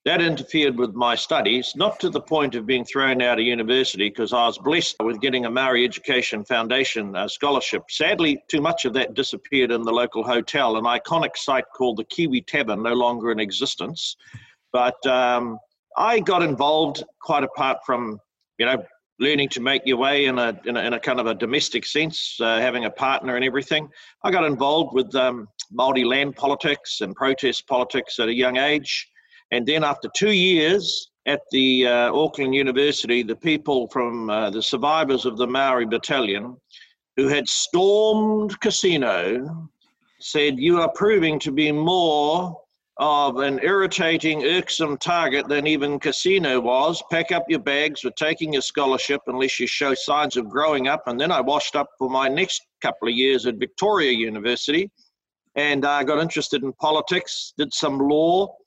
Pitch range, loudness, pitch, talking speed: 125-155 Hz, -21 LUFS, 140 Hz, 180 wpm